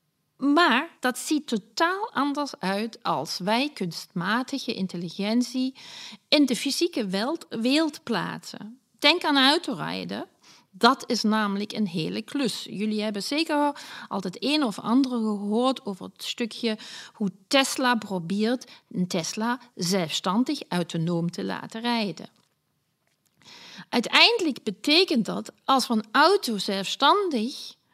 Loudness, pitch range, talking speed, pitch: -25 LUFS, 205-275 Hz, 120 wpm, 235 Hz